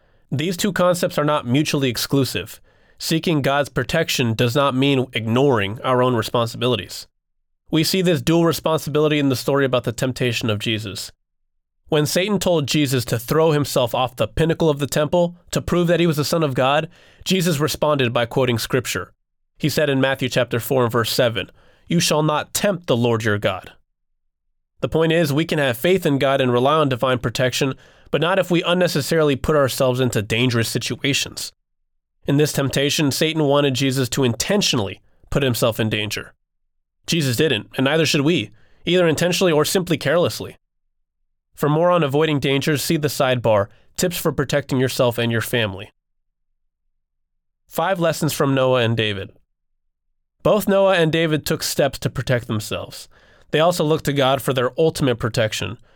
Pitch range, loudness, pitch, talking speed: 115-155 Hz, -19 LUFS, 135 Hz, 170 wpm